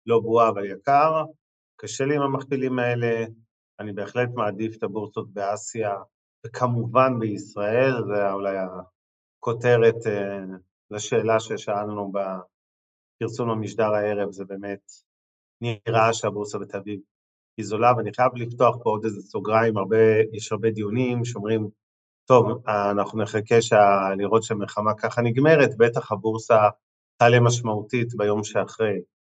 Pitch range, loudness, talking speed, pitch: 100-115 Hz, -23 LUFS, 120 wpm, 110 Hz